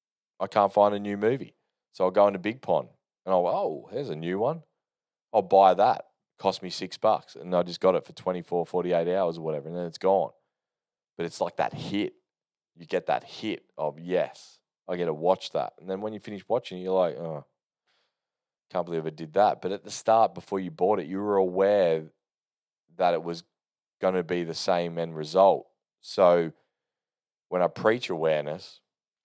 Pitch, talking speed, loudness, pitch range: 90 Hz, 200 wpm, -27 LUFS, 85-95 Hz